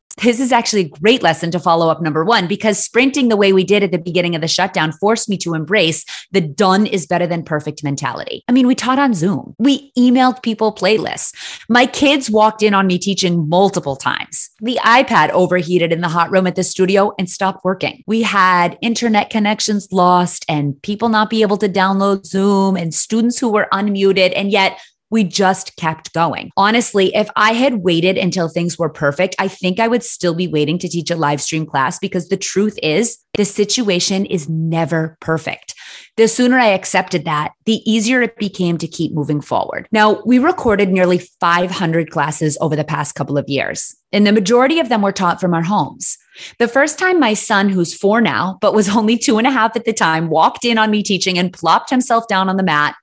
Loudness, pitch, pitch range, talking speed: -15 LUFS, 195 Hz, 170-220 Hz, 210 wpm